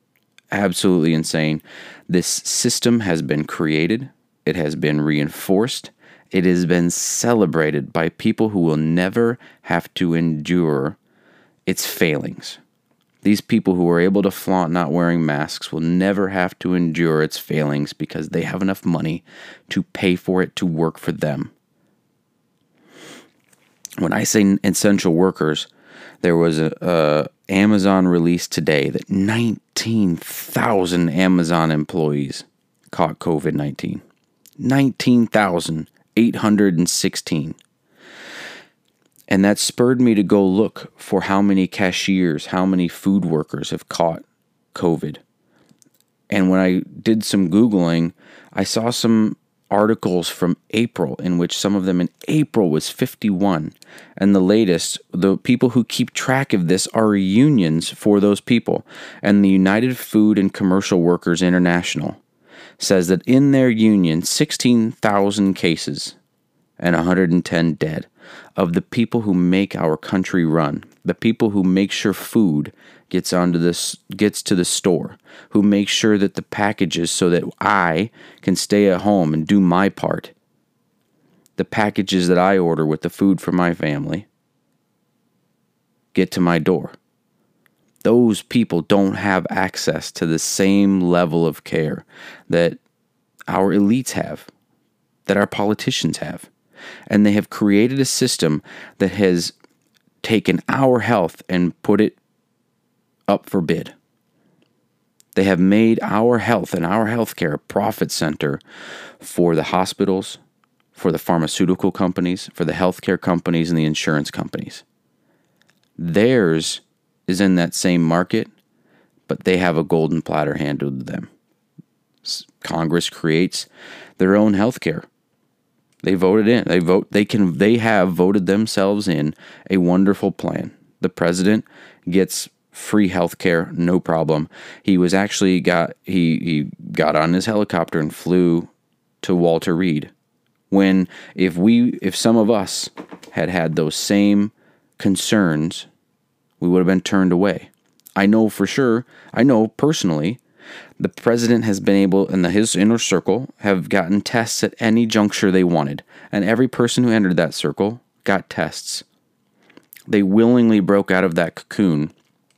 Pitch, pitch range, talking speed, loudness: 95 Hz, 85-105 Hz, 140 wpm, -18 LUFS